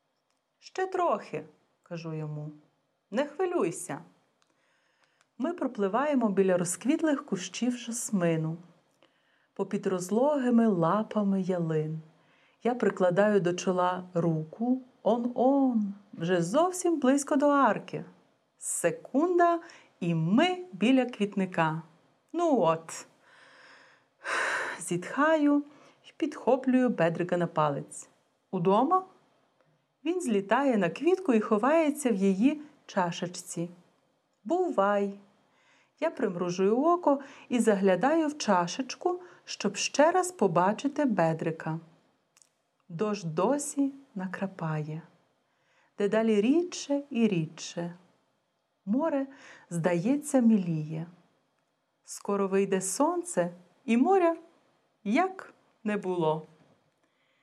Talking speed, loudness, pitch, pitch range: 85 wpm, -28 LUFS, 210 Hz, 175-285 Hz